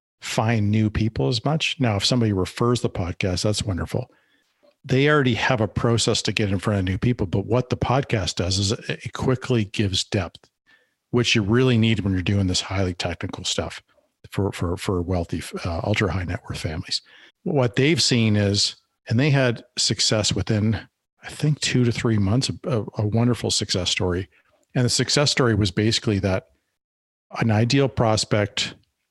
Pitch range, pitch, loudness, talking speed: 100-125 Hz, 110 Hz, -22 LUFS, 175 wpm